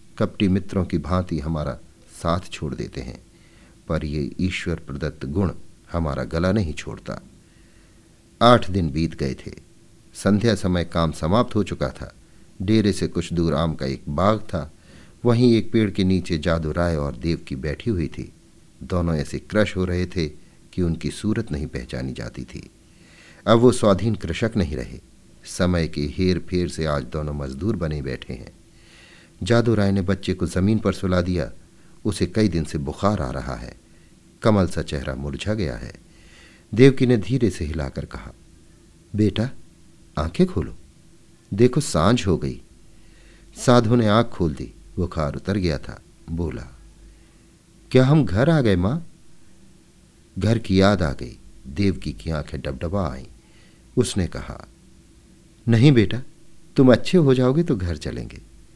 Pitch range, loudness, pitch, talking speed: 80-105 Hz, -22 LUFS, 90 Hz, 160 wpm